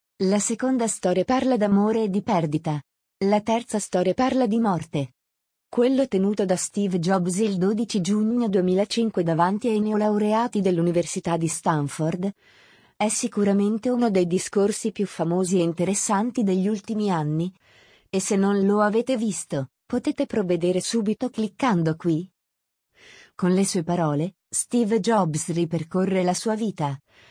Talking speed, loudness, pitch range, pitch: 135 wpm, -23 LUFS, 175-220 Hz, 200 Hz